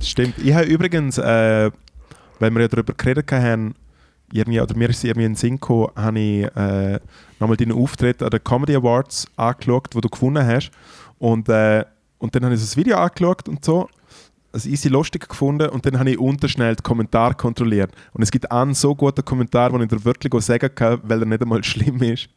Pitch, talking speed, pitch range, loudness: 120 Hz, 205 wpm, 110-135 Hz, -19 LUFS